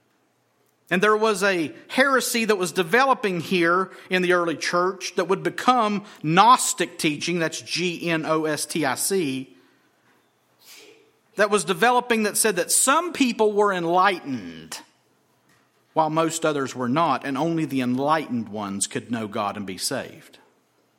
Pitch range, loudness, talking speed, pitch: 160-220 Hz, -22 LUFS, 150 wpm, 185 Hz